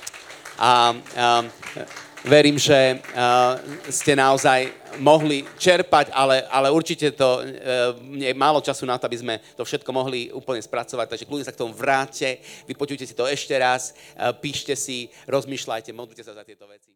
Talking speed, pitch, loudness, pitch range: 165 wpm, 130 Hz, -21 LUFS, 125-140 Hz